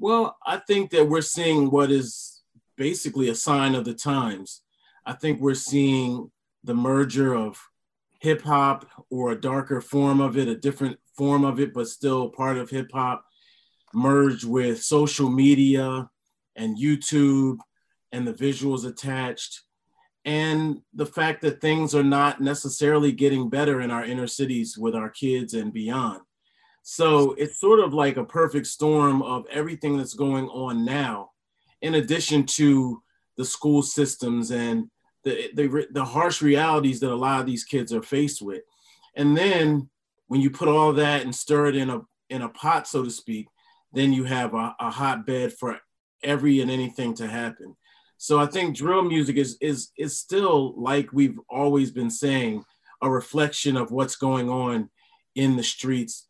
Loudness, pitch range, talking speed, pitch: -23 LUFS, 130-150 Hz, 170 wpm, 140 Hz